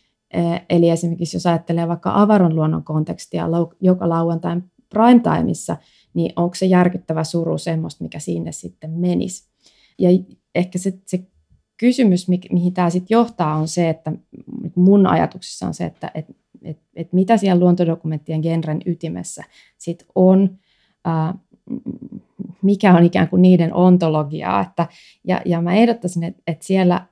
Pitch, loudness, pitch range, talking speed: 175 Hz, -18 LUFS, 165-185 Hz, 145 wpm